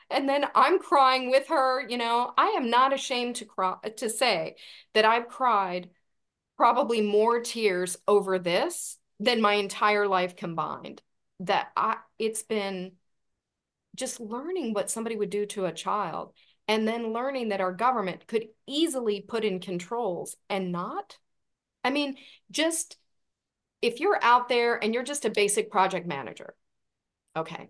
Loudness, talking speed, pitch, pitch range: -27 LUFS, 150 wpm, 225 Hz, 195-255 Hz